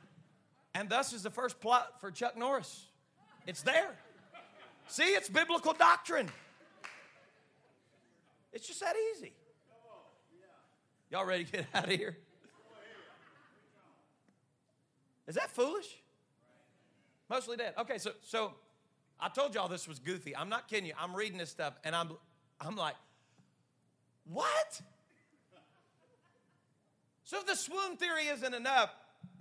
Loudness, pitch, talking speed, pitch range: -35 LUFS, 215 Hz, 120 wpm, 180-285 Hz